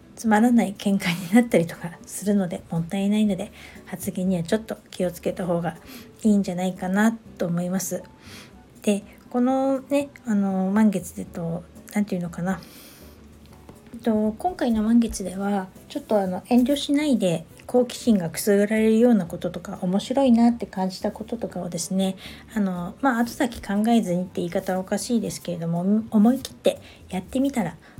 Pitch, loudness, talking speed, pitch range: 200 Hz, -24 LUFS, 355 characters per minute, 185-230 Hz